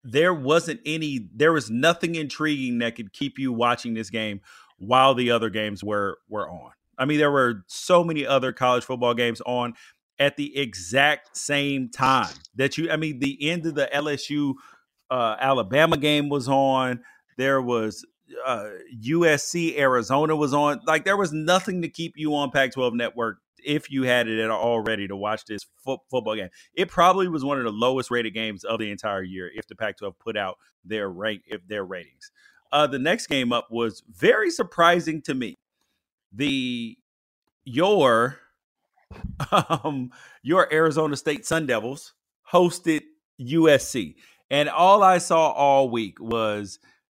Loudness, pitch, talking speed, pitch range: -23 LUFS, 140 Hz, 165 wpm, 120-160 Hz